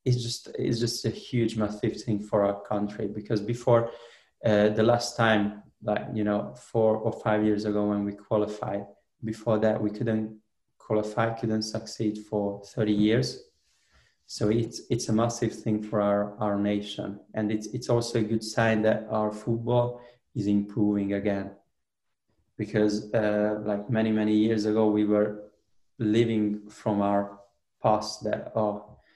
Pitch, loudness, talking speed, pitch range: 105 Hz, -27 LUFS, 155 wpm, 105-115 Hz